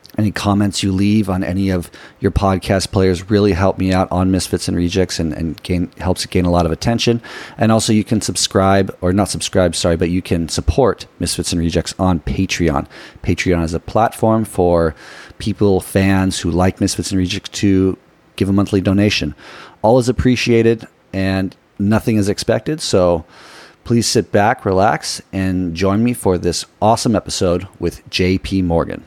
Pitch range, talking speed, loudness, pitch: 90-105 Hz, 175 wpm, -16 LUFS, 95 Hz